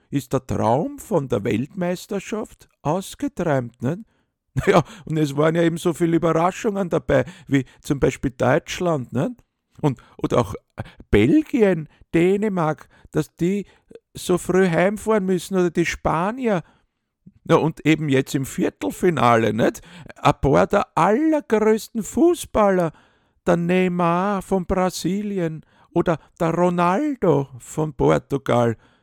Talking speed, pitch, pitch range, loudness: 120 wpm, 175 Hz, 150-195 Hz, -21 LUFS